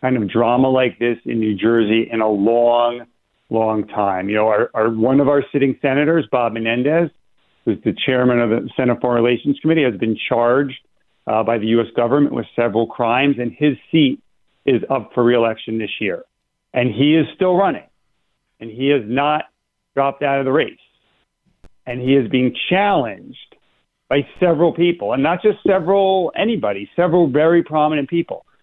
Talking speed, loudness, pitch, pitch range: 175 wpm, -17 LUFS, 130 Hz, 115-150 Hz